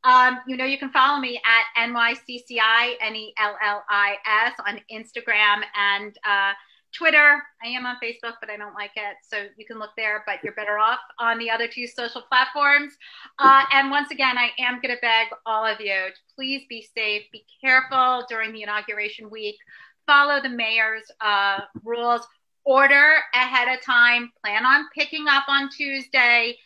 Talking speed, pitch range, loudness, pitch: 170 wpm, 215-265 Hz, -20 LUFS, 235 Hz